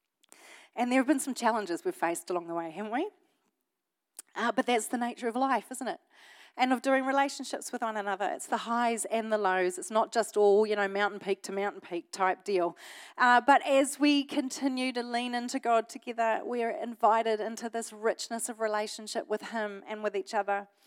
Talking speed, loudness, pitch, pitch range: 205 wpm, -30 LUFS, 230 Hz, 205-255 Hz